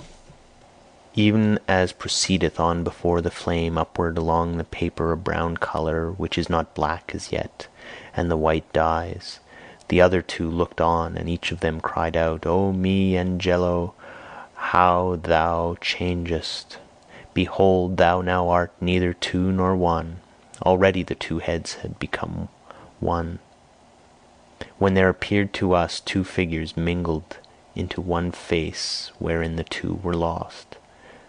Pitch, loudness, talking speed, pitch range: 85 Hz, -23 LUFS, 140 wpm, 85-90 Hz